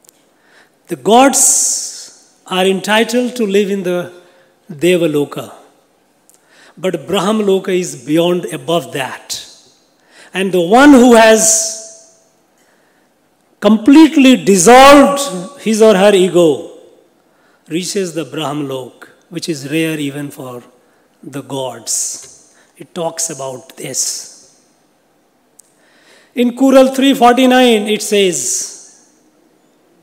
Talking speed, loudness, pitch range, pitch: 90 wpm, -11 LUFS, 165-245 Hz, 190 Hz